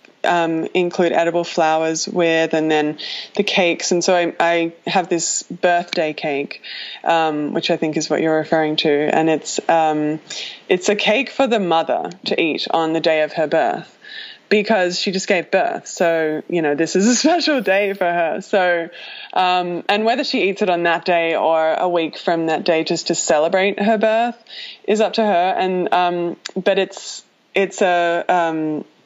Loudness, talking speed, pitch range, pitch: -18 LUFS, 185 wpm, 160-195 Hz, 175 Hz